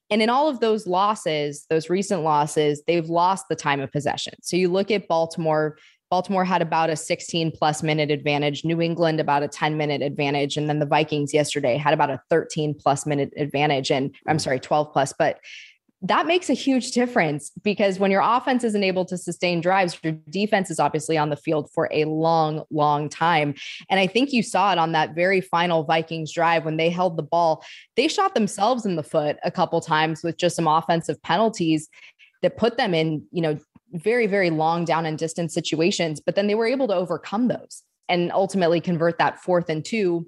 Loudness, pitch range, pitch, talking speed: -22 LUFS, 155-185 Hz, 165 Hz, 205 wpm